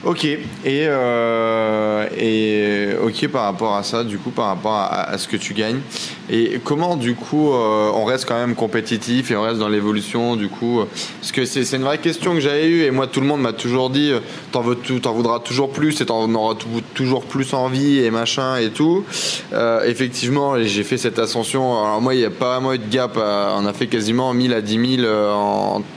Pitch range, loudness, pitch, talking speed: 110-135 Hz, -19 LUFS, 120 Hz, 225 wpm